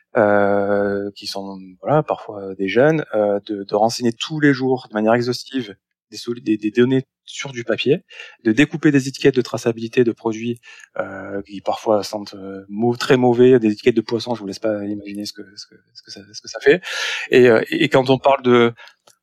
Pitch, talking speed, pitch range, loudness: 110 Hz, 210 wpm, 100-125 Hz, -18 LUFS